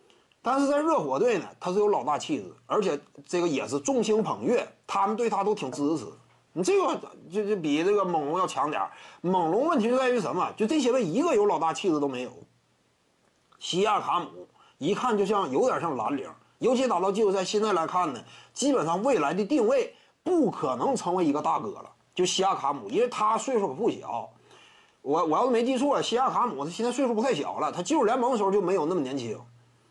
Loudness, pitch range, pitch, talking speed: -27 LUFS, 190-280 Hz, 225 Hz, 320 characters per minute